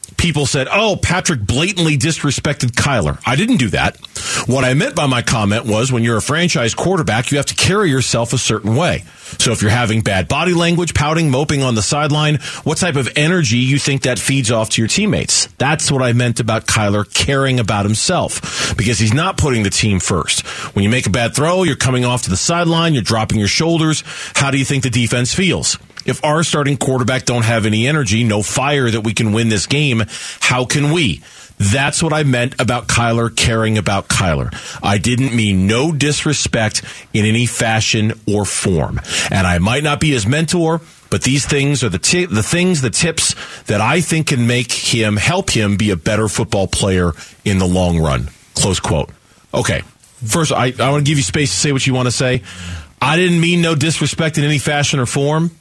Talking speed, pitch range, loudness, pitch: 210 wpm, 110-150 Hz, -15 LUFS, 125 Hz